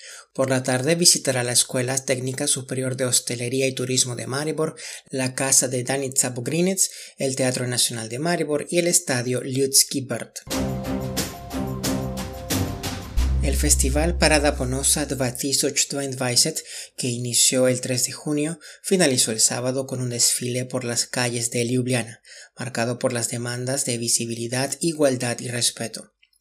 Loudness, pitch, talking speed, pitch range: -22 LUFS, 130 Hz, 135 wpm, 120-135 Hz